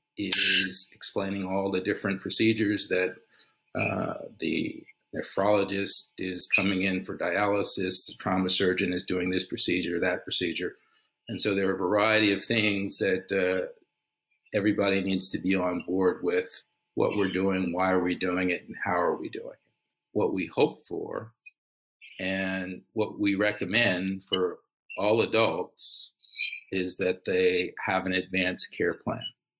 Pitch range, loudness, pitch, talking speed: 95-105 Hz, -27 LUFS, 95 Hz, 150 wpm